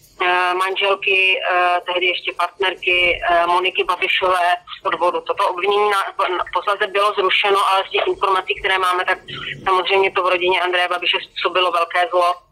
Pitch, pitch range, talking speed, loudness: 185 Hz, 180-195 Hz, 145 wpm, -17 LUFS